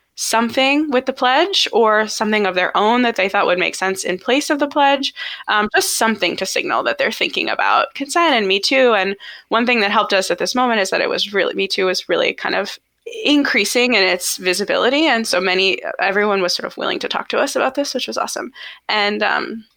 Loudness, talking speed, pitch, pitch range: -16 LUFS, 230 wpm, 225 Hz, 195-275 Hz